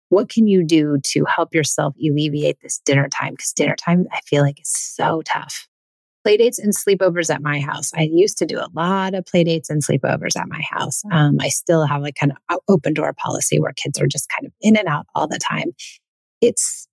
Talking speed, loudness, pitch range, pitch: 220 wpm, -18 LUFS, 150-195 Hz, 165 Hz